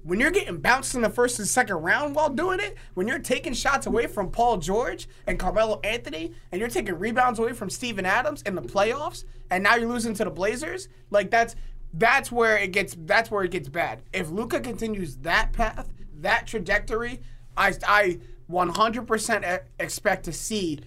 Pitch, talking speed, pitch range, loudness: 205 Hz, 190 wpm, 180-235 Hz, -25 LUFS